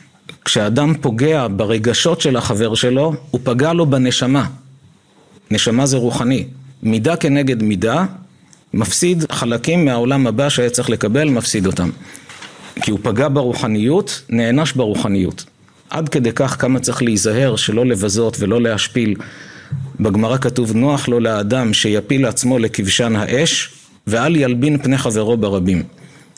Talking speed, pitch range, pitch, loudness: 125 wpm, 110-140 Hz, 125 Hz, -16 LUFS